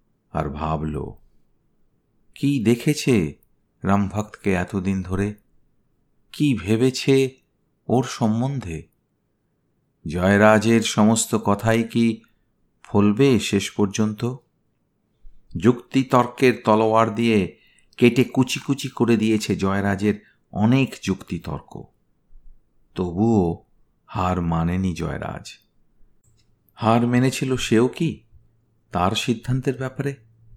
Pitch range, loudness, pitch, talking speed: 100-125 Hz, -21 LUFS, 110 Hz, 80 wpm